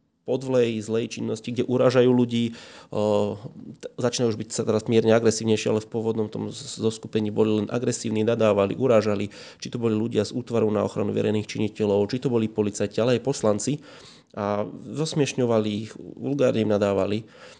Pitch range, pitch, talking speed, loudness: 105-120 Hz, 110 Hz, 155 wpm, -24 LUFS